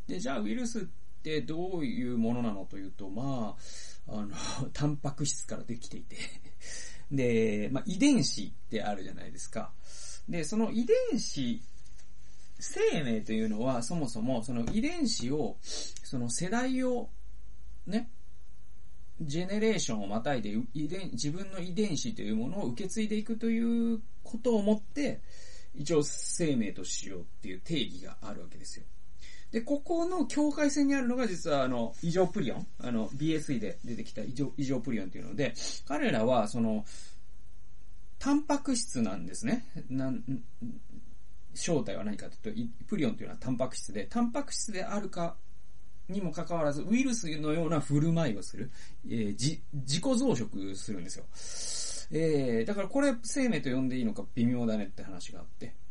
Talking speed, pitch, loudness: 325 characters per minute, 155 Hz, -33 LUFS